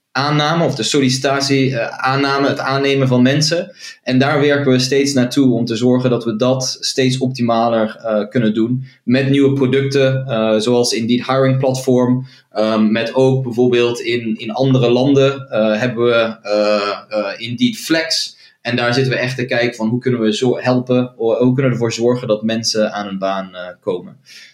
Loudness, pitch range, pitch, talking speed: -15 LUFS, 115-135 Hz, 125 Hz, 185 wpm